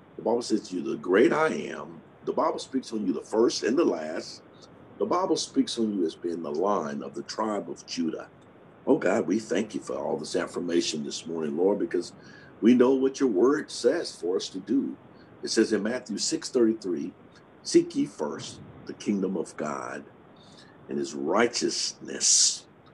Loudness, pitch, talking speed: -27 LUFS, 125 Hz, 185 wpm